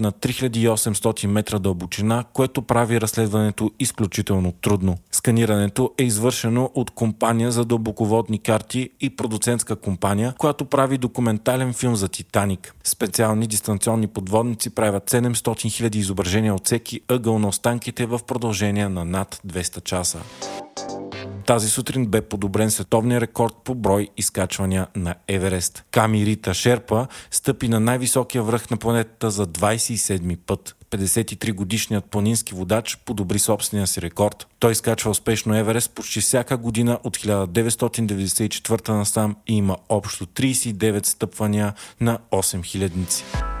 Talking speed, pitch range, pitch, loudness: 125 wpm, 100-120 Hz, 110 Hz, -21 LUFS